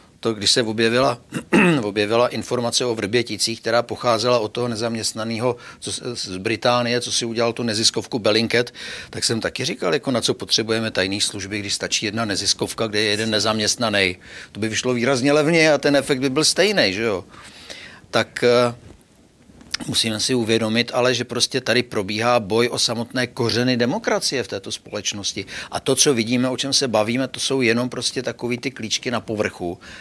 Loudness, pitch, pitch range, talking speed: -20 LUFS, 120 Hz, 110-125 Hz, 175 wpm